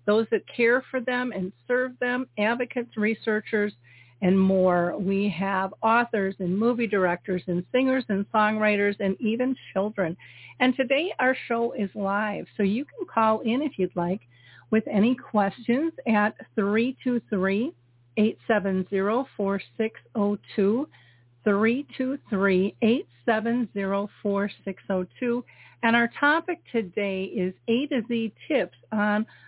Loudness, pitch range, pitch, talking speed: -26 LUFS, 195-240 Hz, 215 Hz, 110 wpm